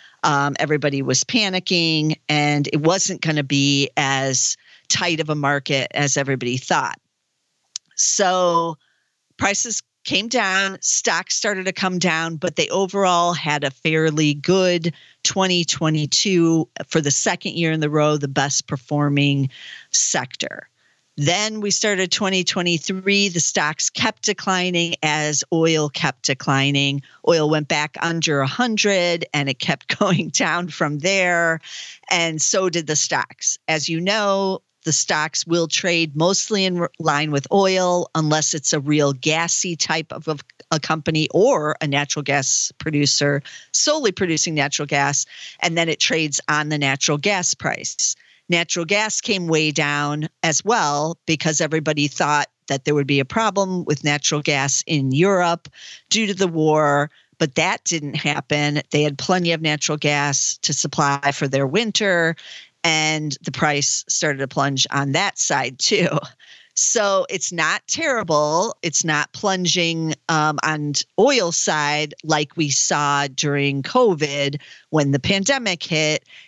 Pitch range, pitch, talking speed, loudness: 145-180 Hz, 155 Hz, 145 wpm, -19 LUFS